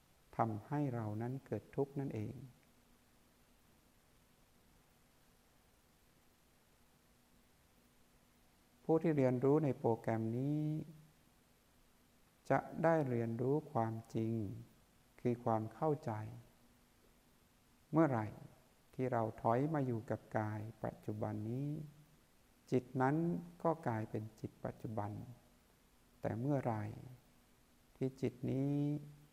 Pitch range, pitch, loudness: 110-145 Hz, 120 Hz, -39 LUFS